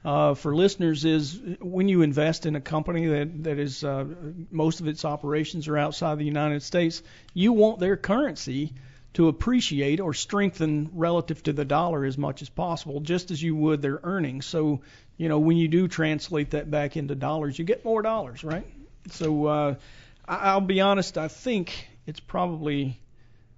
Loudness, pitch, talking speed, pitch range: -26 LUFS, 155 Hz, 180 wpm, 145-170 Hz